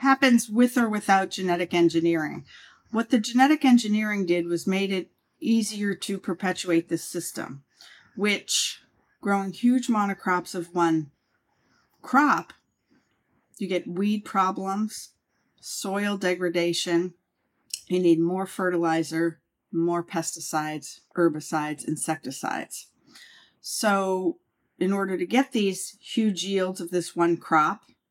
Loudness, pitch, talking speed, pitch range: -25 LUFS, 185 Hz, 110 wpm, 170-205 Hz